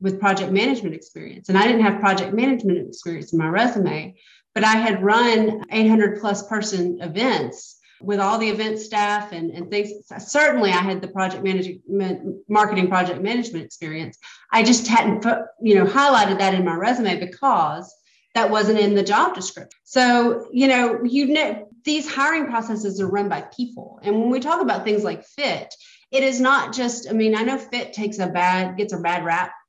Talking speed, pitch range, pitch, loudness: 190 wpm, 190-235 Hz, 210 Hz, -20 LUFS